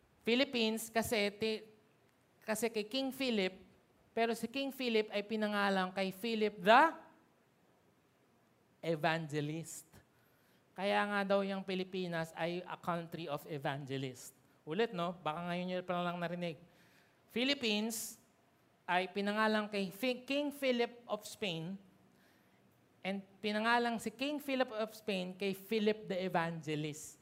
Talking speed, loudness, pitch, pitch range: 115 wpm, -36 LUFS, 200 Hz, 175-225 Hz